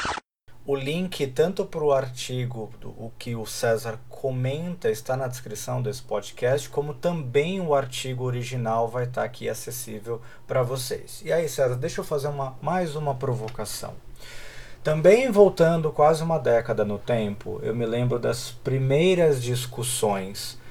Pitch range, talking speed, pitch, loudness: 115-150 Hz, 150 wpm, 130 Hz, -25 LUFS